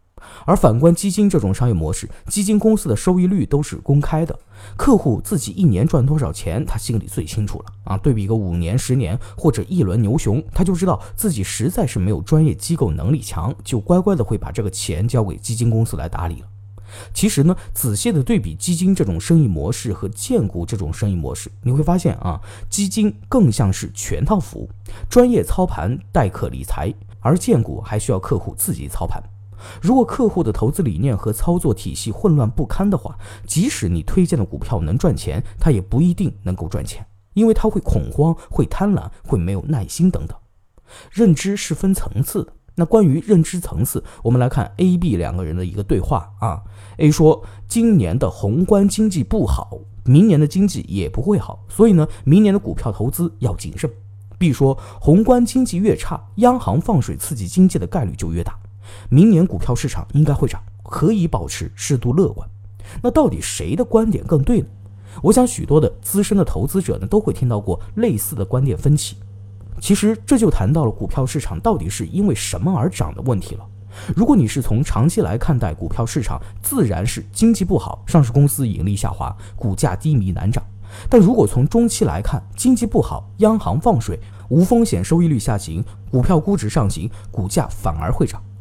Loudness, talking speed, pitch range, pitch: -18 LUFS, 295 characters per minute, 100-170 Hz, 120 Hz